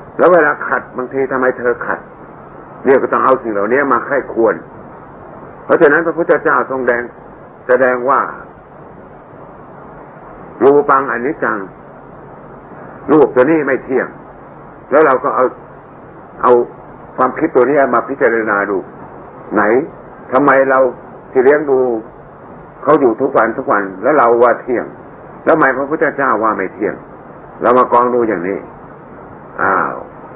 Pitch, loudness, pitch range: 130 Hz, -13 LUFS, 120-135 Hz